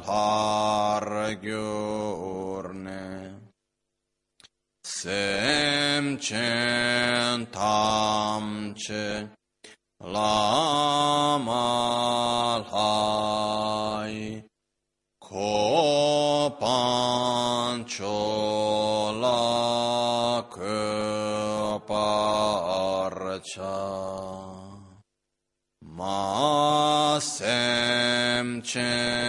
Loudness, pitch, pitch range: -25 LUFS, 105 Hz, 100-120 Hz